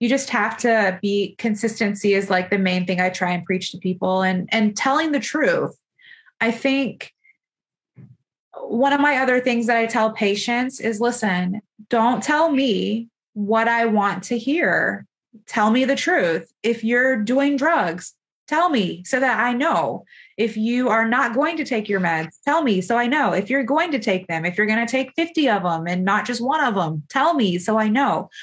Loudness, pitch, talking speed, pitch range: -20 LUFS, 230 Hz, 205 wpm, 200-260 Hz